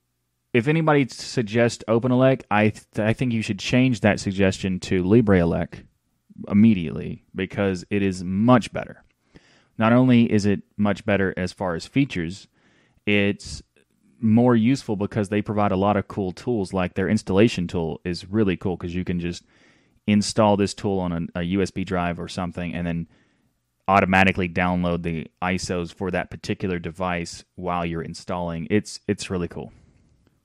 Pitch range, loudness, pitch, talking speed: 90-110 Hz, -22 LUFS, 95 Hz, 160 wpm